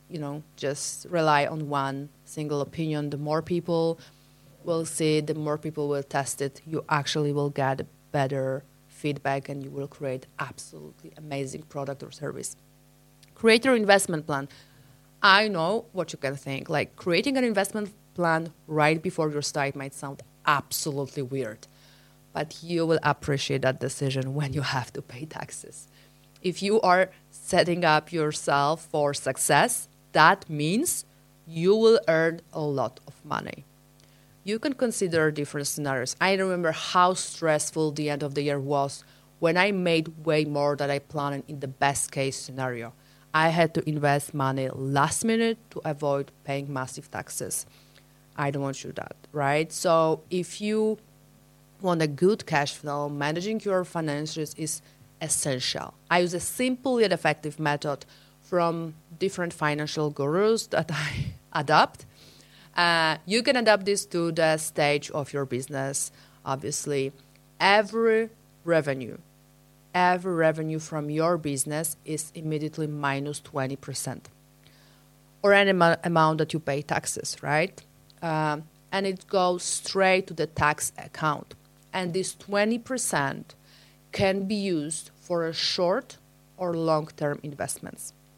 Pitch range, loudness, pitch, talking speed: 140-170 Hz, -26 LUFS, 150 Hz, 145 wpm